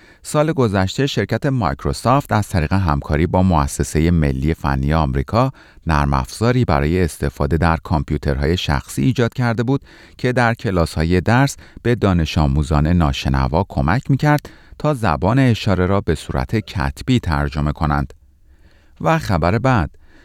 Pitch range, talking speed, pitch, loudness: 75-115 Hz, 130 wpm, 85 Hz, -18 LUFS